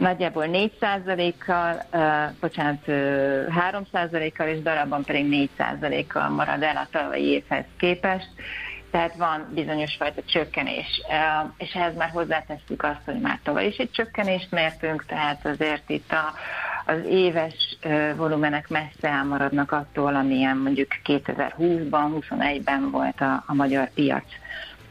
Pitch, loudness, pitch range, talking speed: 155 Hz, -25 LUFS, 145-170 Hz, 125 wpm